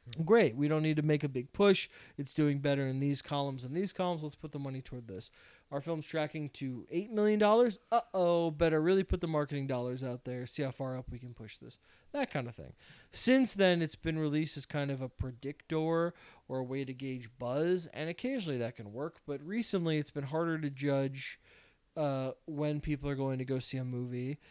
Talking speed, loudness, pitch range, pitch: 220 wpm, -34 LUFS, 130-165 Hz, 145 Hz